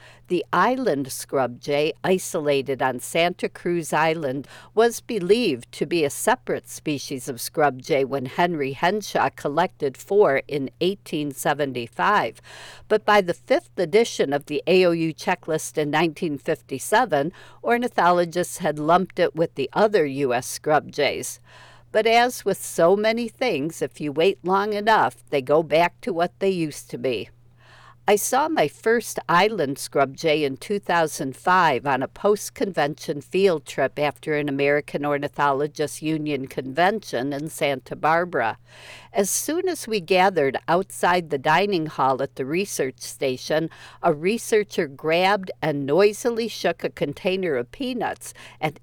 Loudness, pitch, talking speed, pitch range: -23 LUFS, 160 Hz, 145 wpm, 140-195 Hz